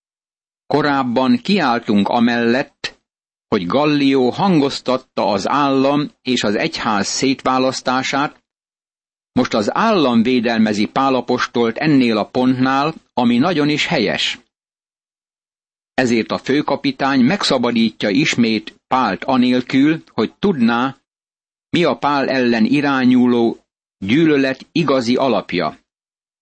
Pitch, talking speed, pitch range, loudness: 130 Hz, 95 wpm, 120-145 Hz, -16 LUFS